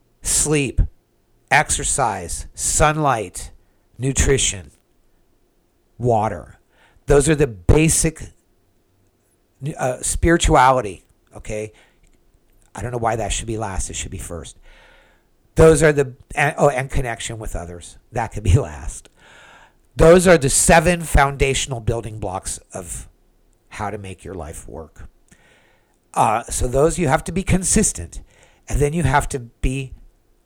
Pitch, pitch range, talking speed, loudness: 115 Hz, 90-140 Hz, 130 wpm, -18 LUFS